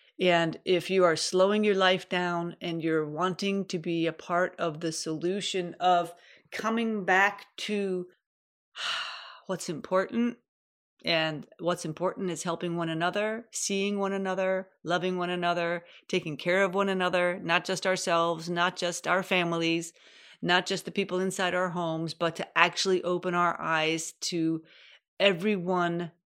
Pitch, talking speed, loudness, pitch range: 180 Hz, 145 wpm, -28 LUFS, 170-190 Hz